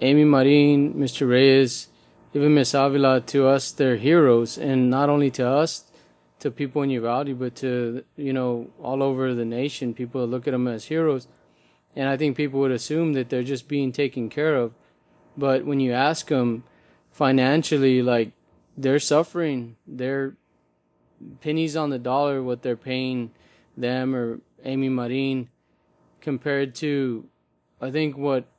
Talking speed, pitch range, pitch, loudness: 155 wpm, 125-145 Hz, 135 Hz, -23 LUFS